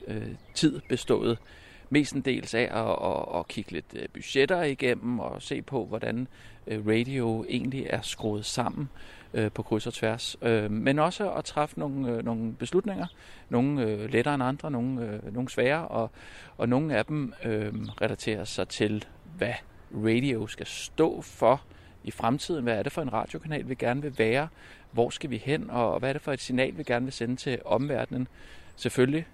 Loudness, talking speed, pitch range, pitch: -29 LUFS, 170 wpm, 110-135 Hz, 120 Hz